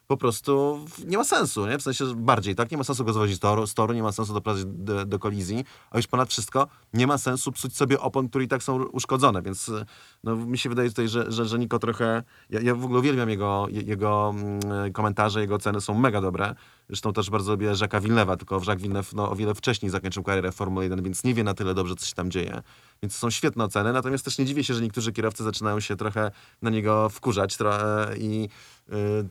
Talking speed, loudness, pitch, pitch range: 225 wpm, -26 LUFS, 110 Hz, 105-125 Hz